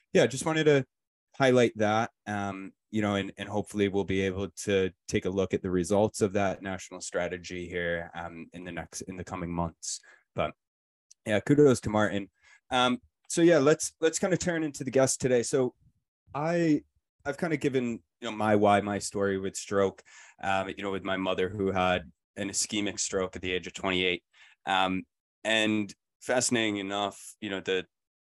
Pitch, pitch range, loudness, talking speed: 100 Hz, 95-120 Hz, -29 LUFS, 190 wpm